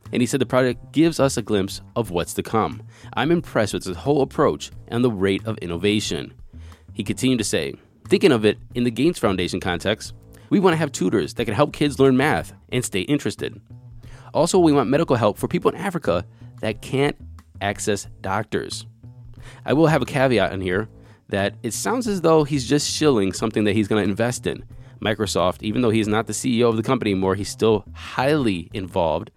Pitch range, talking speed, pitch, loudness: 100-125 Hz, 205 wpm, 110 Hz, -21 LUFS